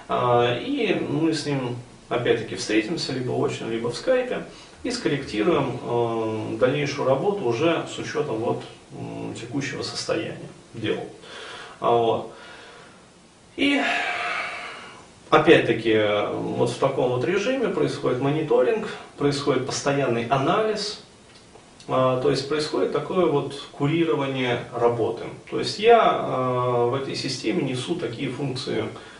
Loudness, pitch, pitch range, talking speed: -24 LUFS, 135 Hz, 120-155 Hz, 105 wpm